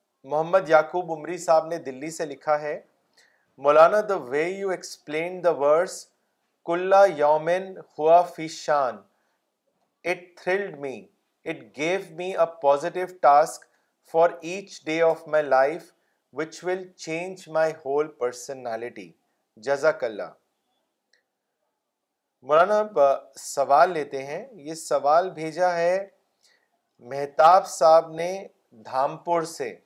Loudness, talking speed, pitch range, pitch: -23 LUFS, 80 wpm, 150-180 Hz, 165 Hz